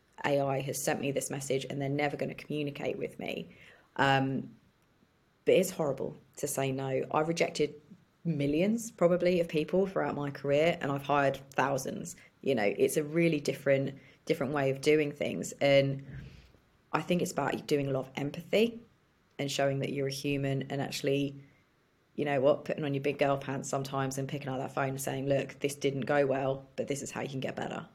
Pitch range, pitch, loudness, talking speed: 135-150 Hz, 140 Hz, -31 LUFS, 200 wpm